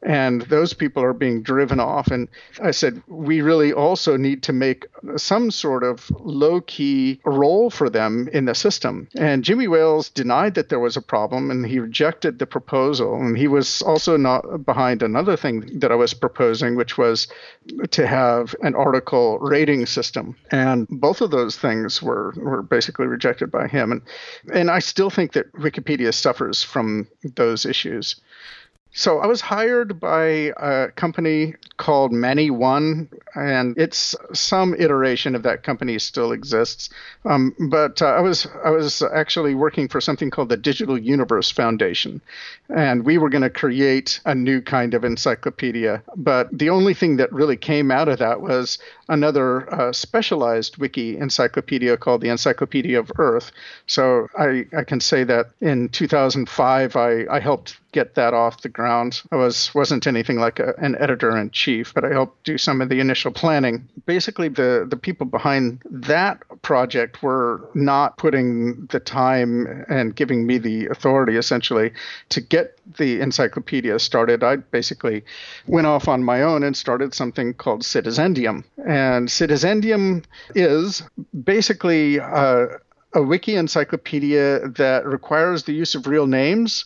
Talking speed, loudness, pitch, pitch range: 160 wpm, -19 LUFS, 140 Hz, 125-155 Hz